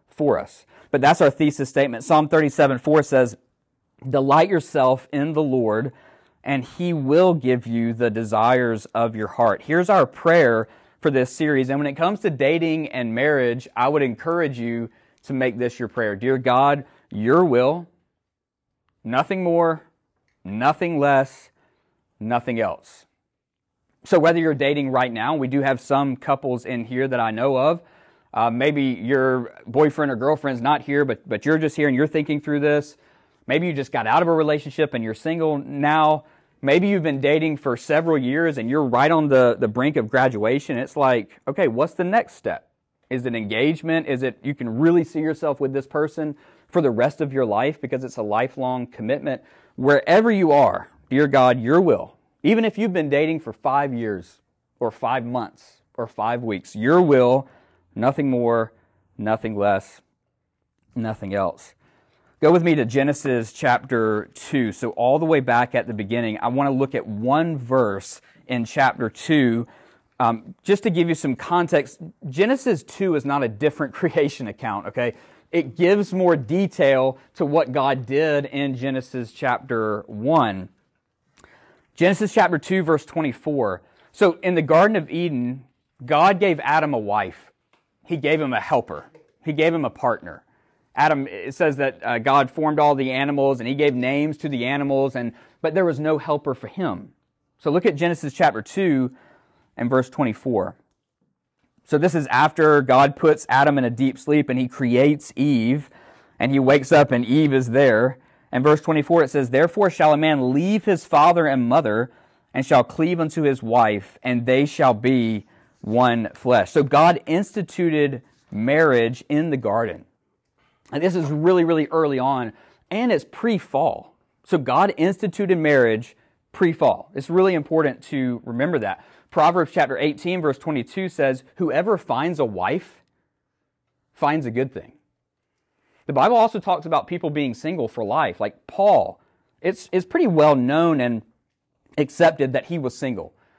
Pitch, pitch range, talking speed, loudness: 140 Hz, 125-160 Hz, 170 wpm, -20 LUFS